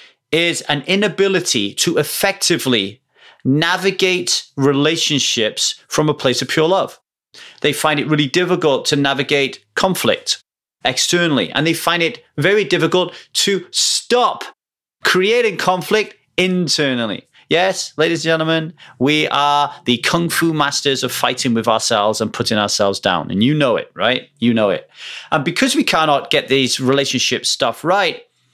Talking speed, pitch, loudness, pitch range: 145 wpm, 155 Hz, -16 LUFS, 135-180 Hz